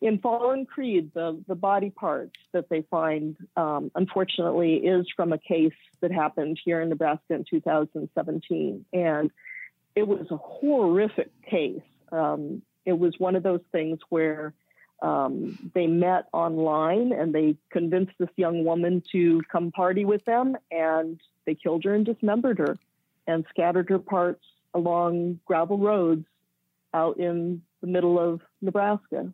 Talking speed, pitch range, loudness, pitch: 145 wpm, 160-190 Hz, -26 LUFS, 175 Hz